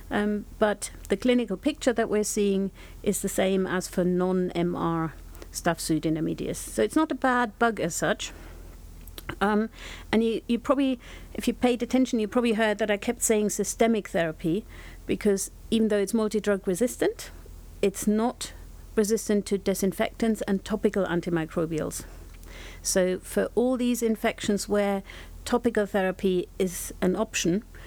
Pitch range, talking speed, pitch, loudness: 180-225 Hz, 145 wpm, 205 Hz, -26 LUFS